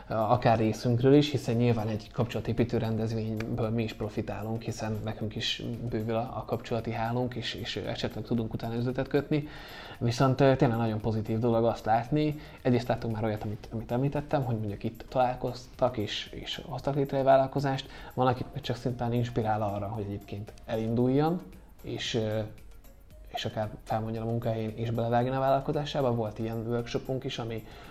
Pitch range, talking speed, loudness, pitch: 110-130 Hz, 160 wpm, -30 LUFS, 115 Hz